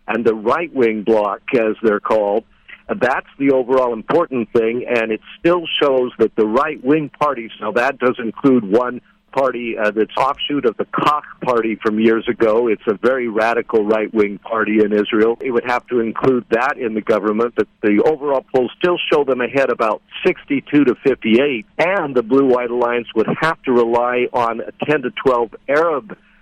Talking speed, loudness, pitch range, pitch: 190 wpm, -17 LUFS, 110-135 Hz, 120 Hz